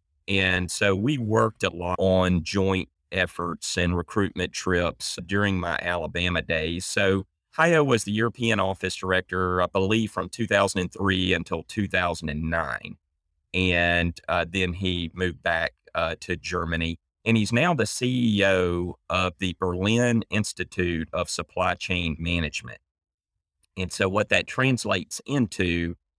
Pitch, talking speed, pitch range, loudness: 90 Hz, 130 wpm, 85-100 Hz, -25 LUFS